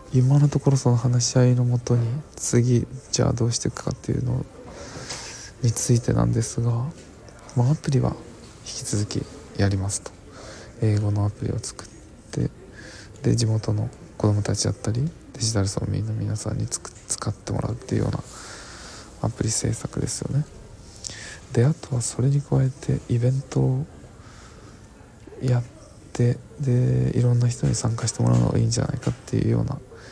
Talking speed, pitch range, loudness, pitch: 325 characters per minute, 105-130 Hz, -24 LUFS, 120 Hz